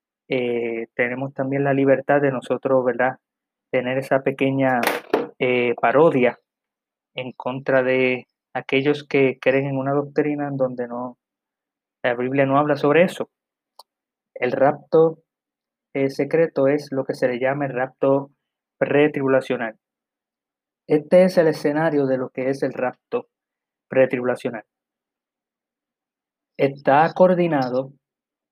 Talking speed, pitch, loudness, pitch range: 120 wpm, 135 Hz, -21 LUFS, 130-145 Hz